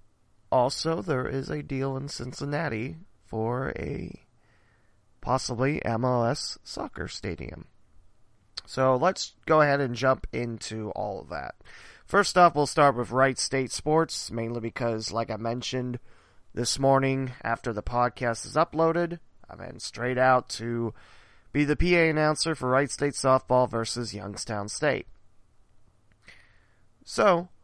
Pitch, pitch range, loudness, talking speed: 120 Hz, 110-140 Hz, -27 LUFS, 130 wpm